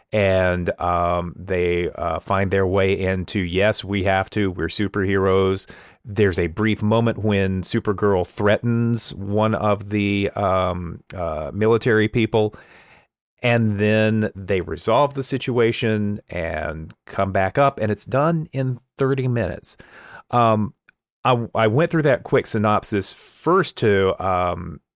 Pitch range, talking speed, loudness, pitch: 95-115 Hz, 130 wpm, -21 LUFS, 105 Hz